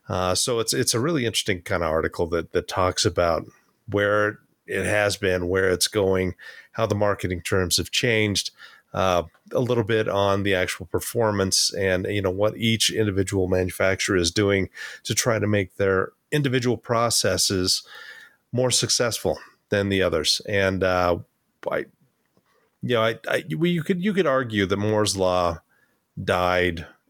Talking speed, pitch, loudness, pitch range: 160 wpm, 100 Hz, -23 LUFS, 95-110 Hz